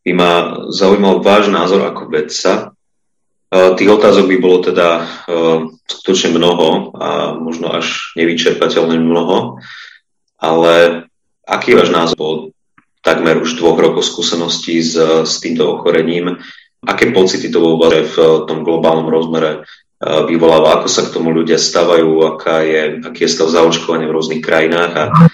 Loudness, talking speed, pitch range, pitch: -12 LUFS, 135 wpm, 80-85 Hz, 80 Hz